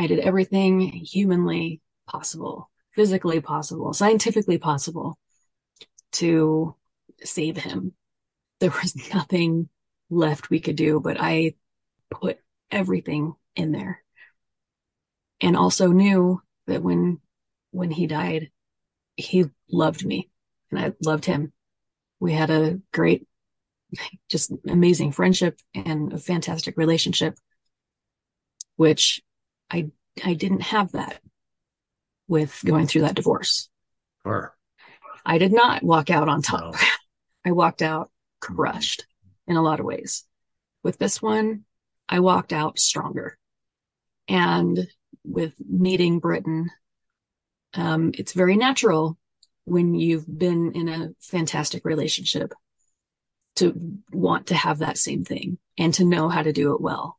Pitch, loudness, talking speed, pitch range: 165 Hz, -23 LUFS, 120 wpm, 155-180 Hz